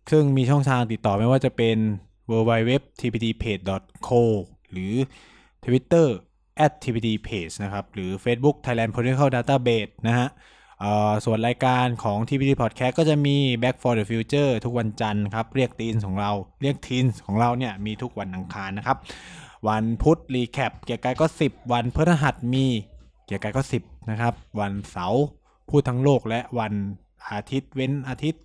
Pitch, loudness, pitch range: 120 Hz, -24 LUFS, 105-130 Hz